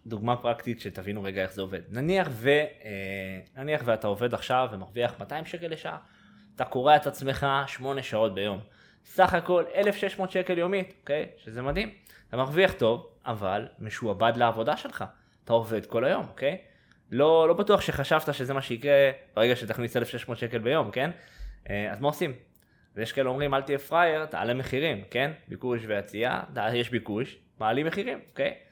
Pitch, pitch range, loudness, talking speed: 130 Hz, 110-150 Hz, -28 LUFS, 170 wpm